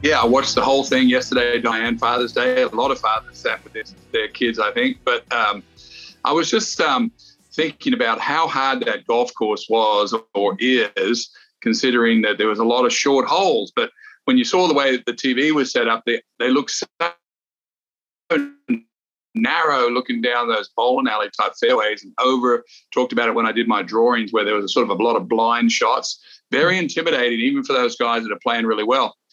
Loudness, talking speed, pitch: -19 LUFS, 205 wpm, 130 Hz